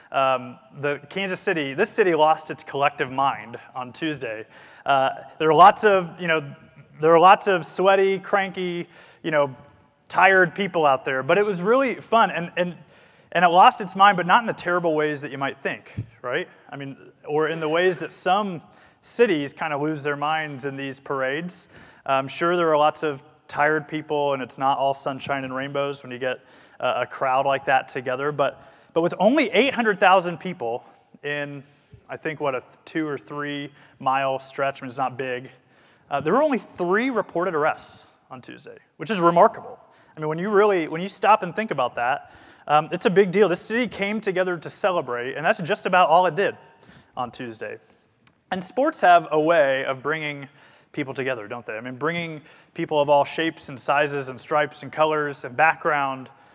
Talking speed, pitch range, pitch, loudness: 200 wpm, 140-185 Hz, 155 Hz, -22 LUFS